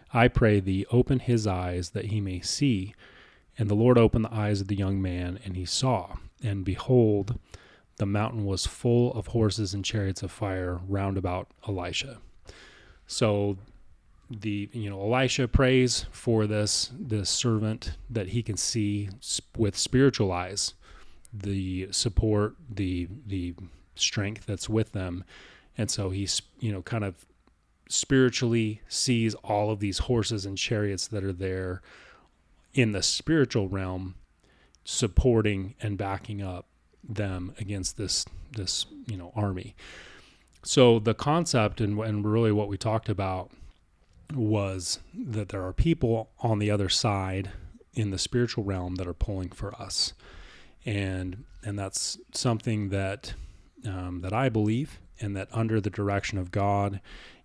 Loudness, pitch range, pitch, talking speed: -28 LUFS, 95-115 Hz, 105 Hz, 145 wpm